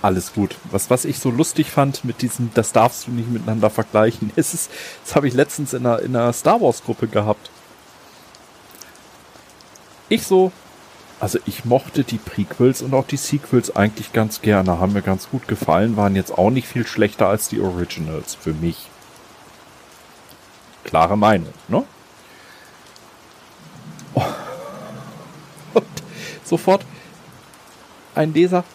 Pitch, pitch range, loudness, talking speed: 120 Hz, 105-150 Hz, -19 LUFS, 140 wpm